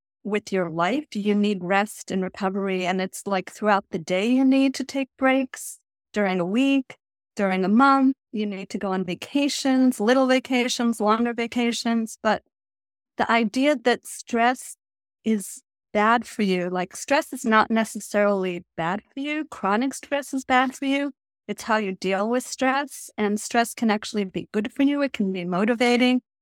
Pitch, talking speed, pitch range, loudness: 220 Hz, 175 wpm, 195-260 Hz, -23 LUFS